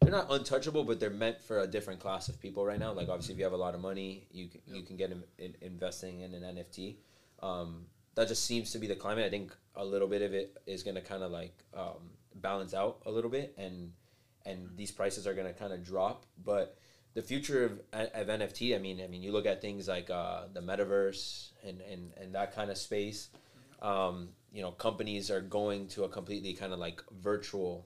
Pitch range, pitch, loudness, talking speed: 95-105 Hz, 95 Hz, -37 LUFS, 235 wpm